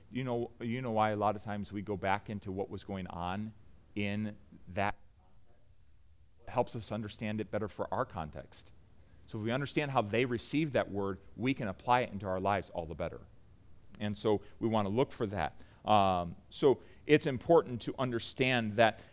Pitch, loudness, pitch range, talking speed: 105 Hz, -34 LUFS, 100-120 Hz, 200 wpm